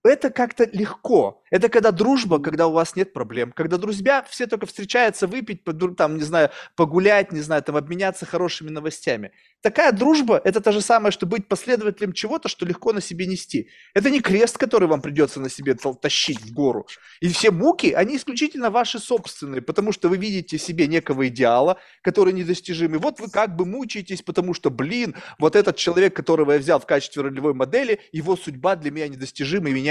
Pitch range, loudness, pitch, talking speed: 155-220 Hz, -21 LUFS, 185 Hz, 190 wpm